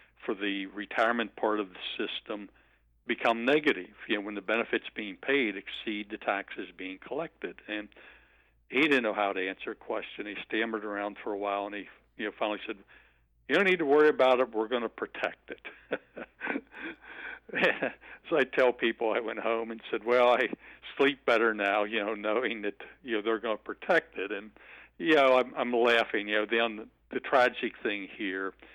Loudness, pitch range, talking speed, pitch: -30 LUFS, 100-115 Hz, 190 wpm, 110 Hz